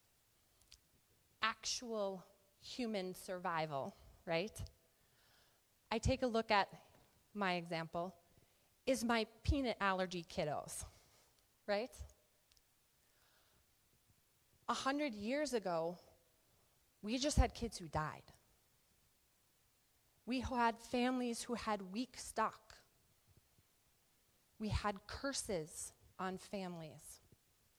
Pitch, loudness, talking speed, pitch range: 205 Hz, -41 LUFS, 85 wpm, 175-235 Hz